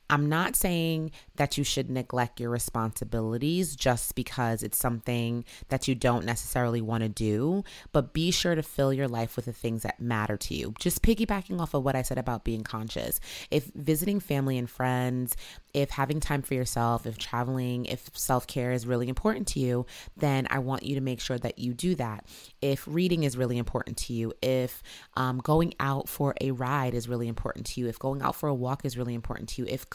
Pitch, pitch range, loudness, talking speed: 125 Hz, 120-140 Hz, -29 LUFS, 210 wpm